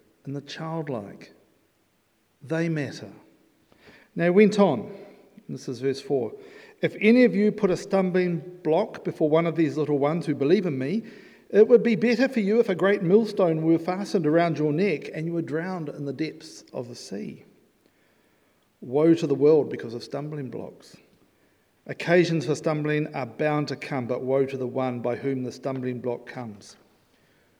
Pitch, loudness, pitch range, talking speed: 160 Hz, -24 LUFS, 135-195 Hz, 180 wpm